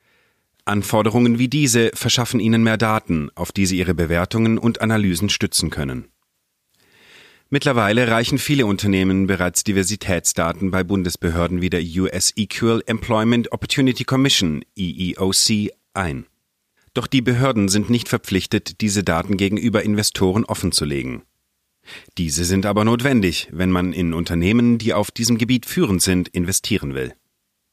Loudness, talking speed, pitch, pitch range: -19 LUFS, 130 wpm, 105 Hz, 90-115 Hz